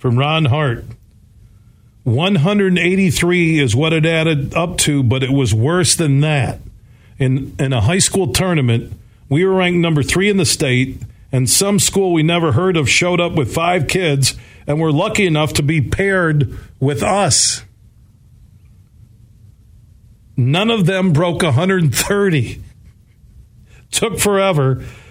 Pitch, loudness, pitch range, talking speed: 140 Hz, -15 LUFS, 115-175 Hz, 140 wpm